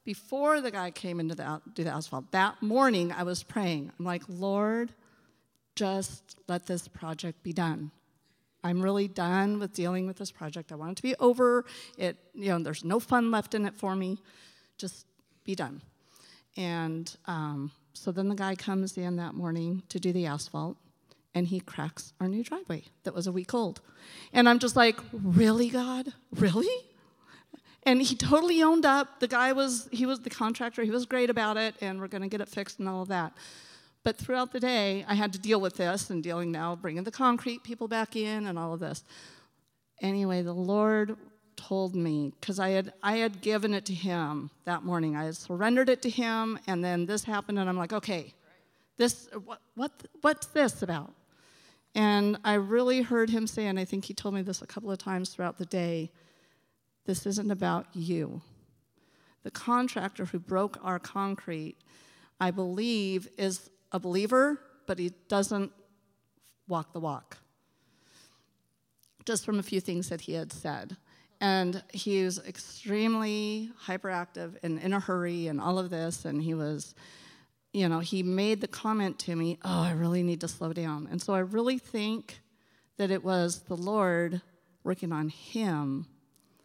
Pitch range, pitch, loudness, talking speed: 175-220 Hz, 190 Hz, -30 LUFS, 185 wpm